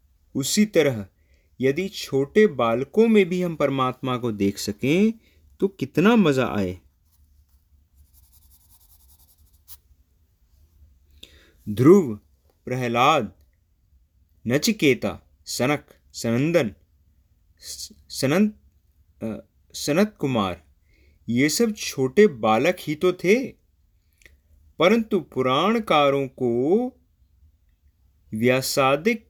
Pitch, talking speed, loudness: 105 Hz, 70 wpm, -22 LUFS